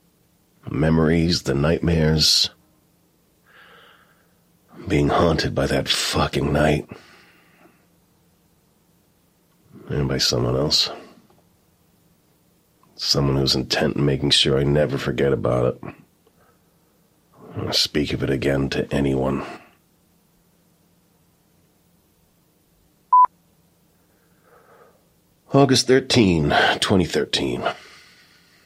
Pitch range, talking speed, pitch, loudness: 70-85 Hz, 75 wpm, 75 Hz, -19 LUFS